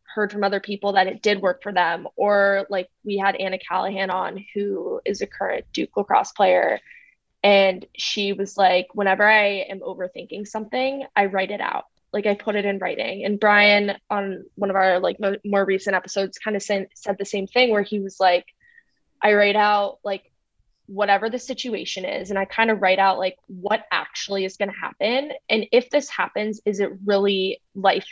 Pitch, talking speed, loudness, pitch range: 200 Hz, 200 wpm, -22 LUFS, 195-210 Hz